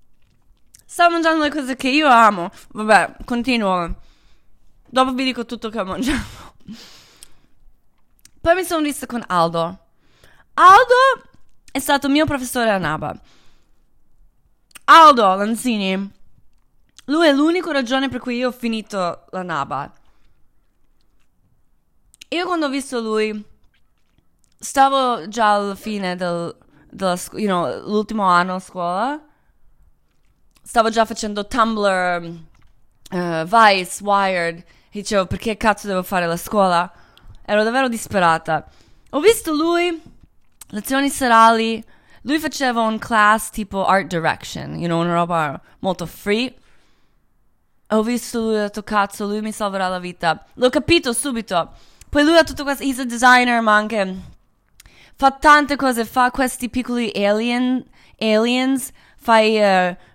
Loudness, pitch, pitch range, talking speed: -18 LUFS, 220 Hz, 190-265 Hz, 130 wpm